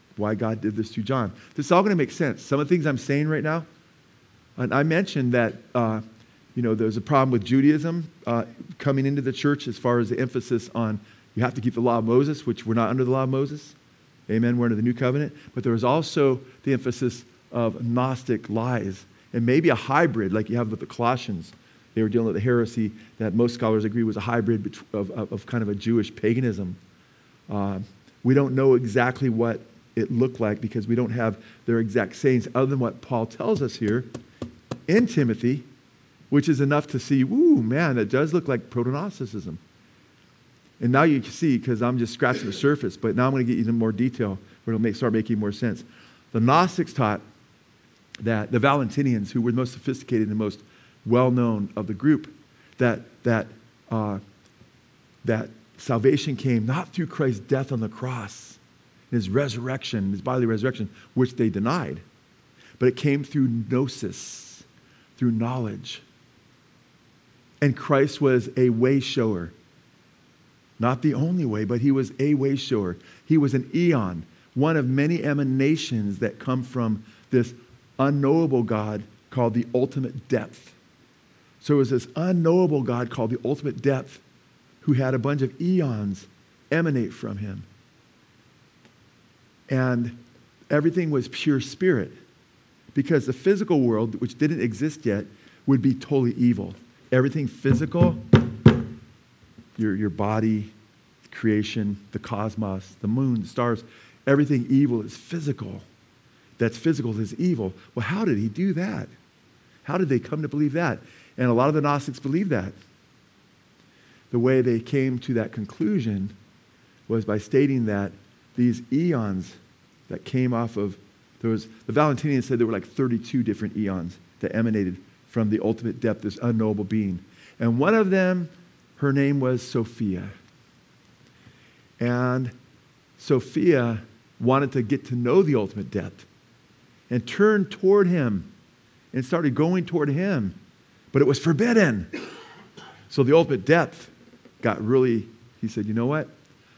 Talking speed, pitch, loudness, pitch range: 165 wpm, 120 Hz, -24 LUFS, 110-140 Hz